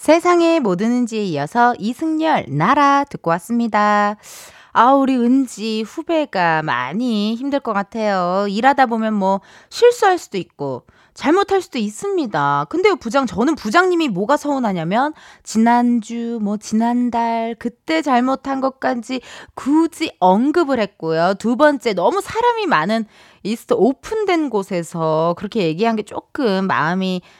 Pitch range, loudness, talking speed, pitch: 205-290 Hz, -18 LUFS, 285 characters per minute, 235 Hz